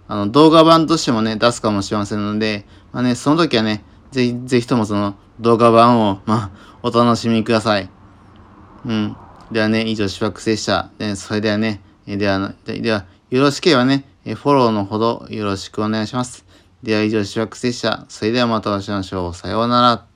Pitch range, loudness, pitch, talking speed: 100-120 Hz, -17 LUFS, 110 Hz, 360 characters per minute